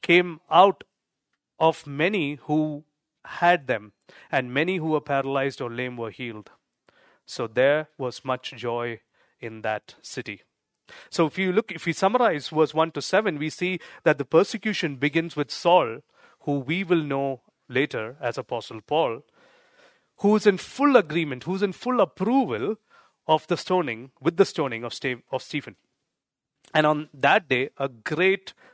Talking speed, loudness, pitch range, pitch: 155 wpm, -24 LUFS, 135-180 Hz, 155 Hz